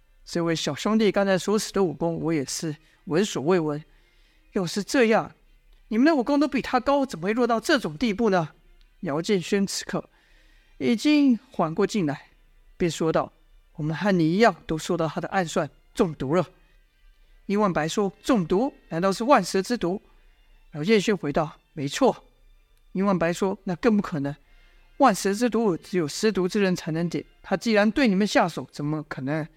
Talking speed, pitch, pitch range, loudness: 255 characters per minute, 190 Hz, 165-220 Hz, -24 LUFS